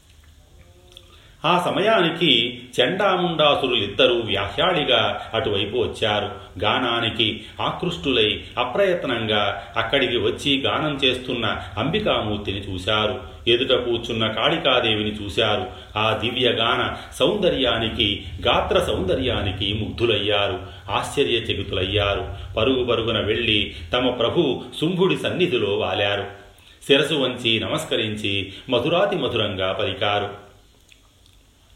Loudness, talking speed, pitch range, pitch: -21 LUFS, 75 wpm, 100-125 Hz, 105 Hz